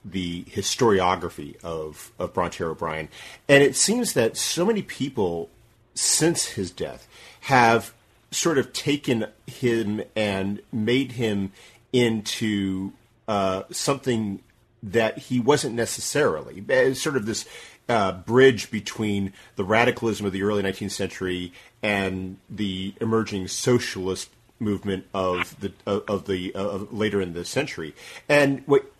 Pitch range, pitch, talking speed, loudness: 95-120 Hz, 105 Hz, 130 wpm, -24 LUFS